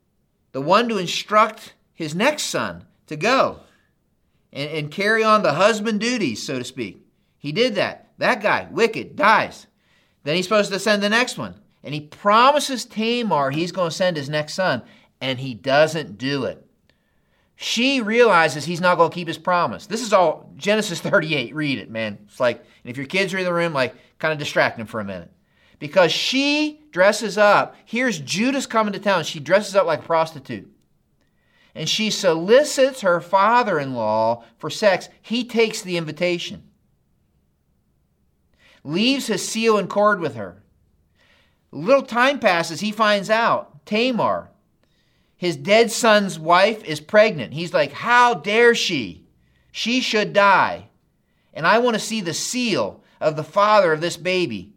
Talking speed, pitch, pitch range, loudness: 170 wpm, 190 Hz, 155-225 Hz, -19 LUFS